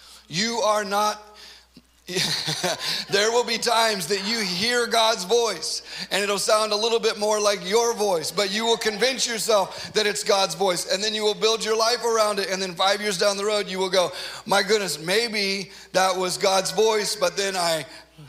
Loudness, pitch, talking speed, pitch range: -22 LUFS, 210 Hz, 200 wpm, 190-220 Hz